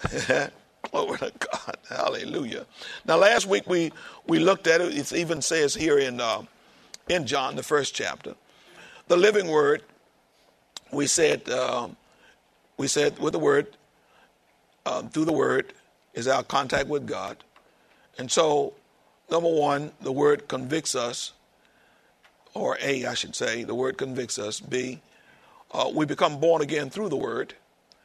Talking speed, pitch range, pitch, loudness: 150 wpm, 145-195 Hz, 165 Hz, -25 LUFS